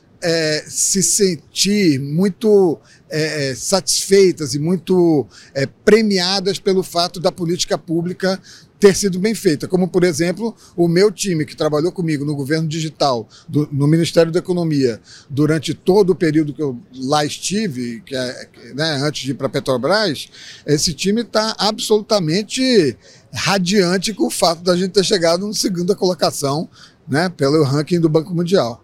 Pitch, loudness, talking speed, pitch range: 170 Hz, -17 LUFS, 155 wpm, 150-190 Hz